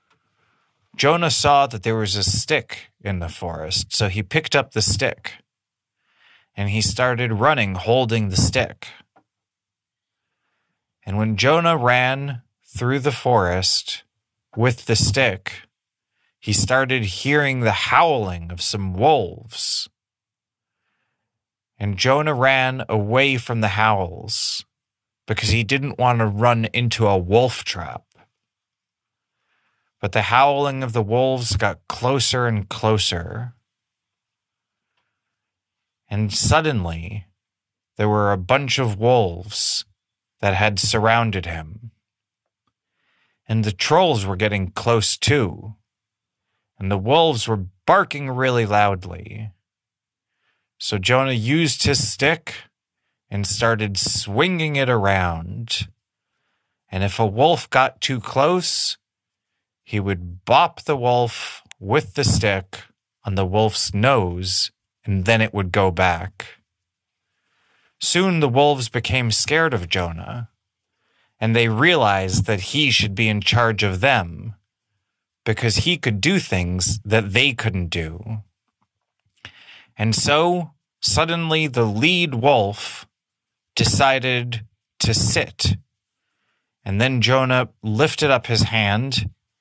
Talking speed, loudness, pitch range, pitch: 115 wpm, -19 LUFS, 100-125 Hz, 110 Hz